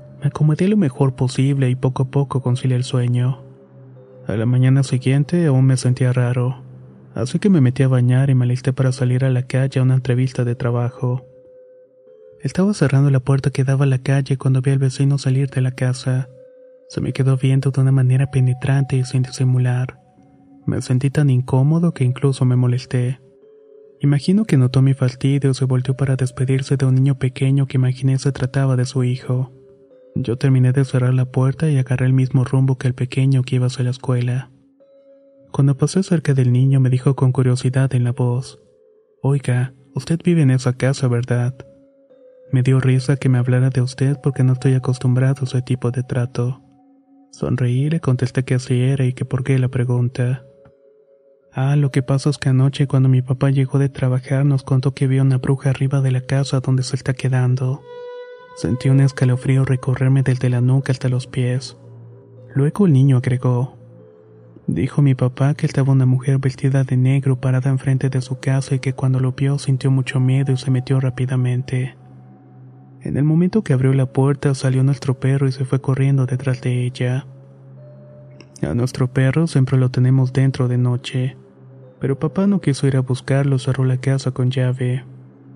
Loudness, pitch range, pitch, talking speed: -18 LUFS, 125-140 Hz, 130 Hz, 190 wpm